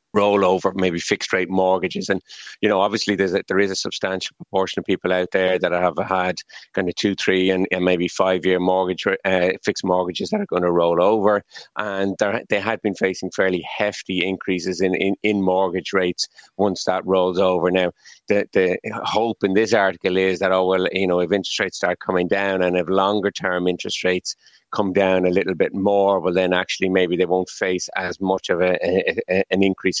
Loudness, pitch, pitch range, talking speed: -20 LUFS, 95 Hz, 90-95 Hz, 210 wpm